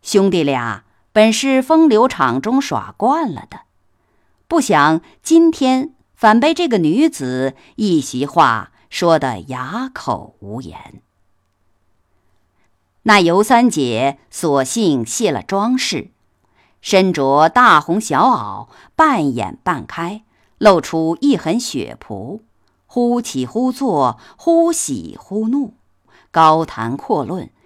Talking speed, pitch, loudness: 150 characters per minute, 175 Hz, -15 LUFS